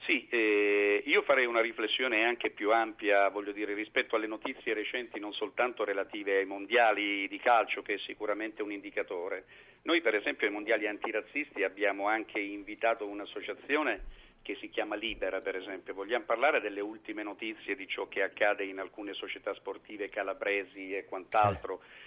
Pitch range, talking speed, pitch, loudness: 100-115 Hz, 160 wpm, 105 Hz, -32 LUFS